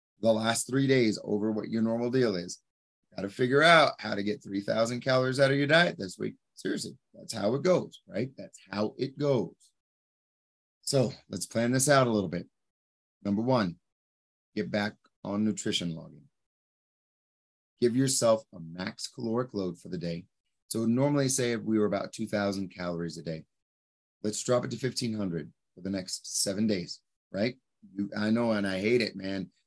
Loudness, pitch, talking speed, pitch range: -29 LUFS, 105 Hz, 180 wpm, 95-125 Hz